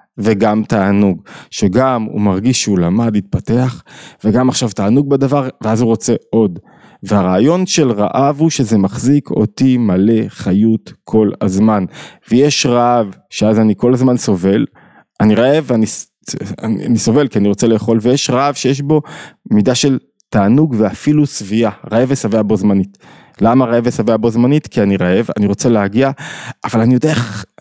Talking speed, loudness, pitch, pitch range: 150 wpm, -13 LUFS, 115 Hz, 105-130 Hz